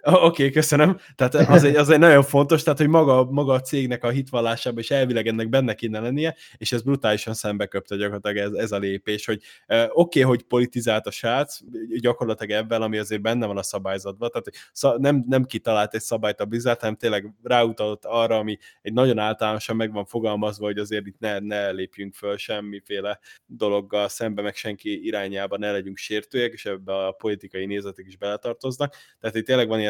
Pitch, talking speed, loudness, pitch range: 110 Hz, 195 wpm, -22 LUFS, 105-130 Hz